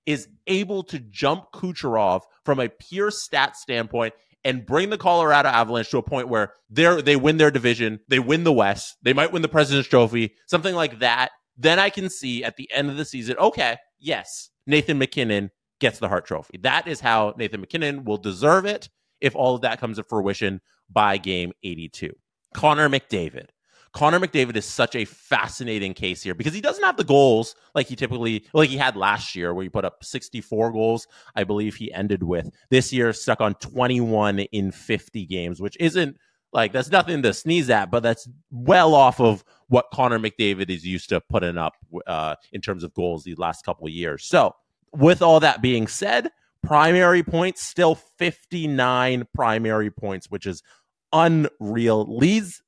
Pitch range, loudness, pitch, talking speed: 105-150 Hz, -21 LUFS, 125 Hz, 185 wpm